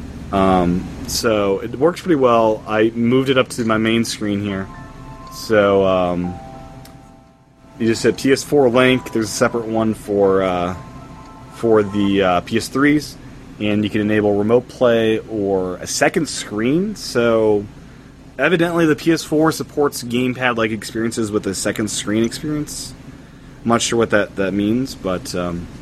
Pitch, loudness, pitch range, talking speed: 115 Hz, -18 LUFS, 105-130 Hz, 150 wpm